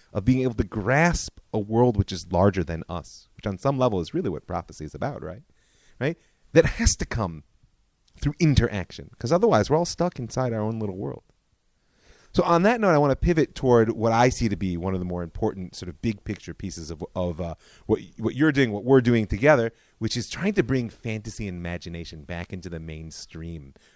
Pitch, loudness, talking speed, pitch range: 110 Hz, -24 LUFS, 220 wpm, 90-130 Hz